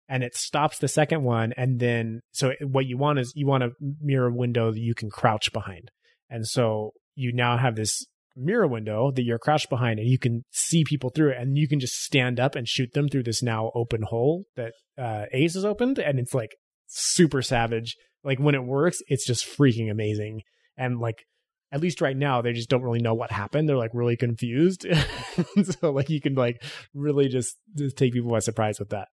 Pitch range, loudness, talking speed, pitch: 115-145 Hz, -25 LUFS, 215 wpm, 125 Hz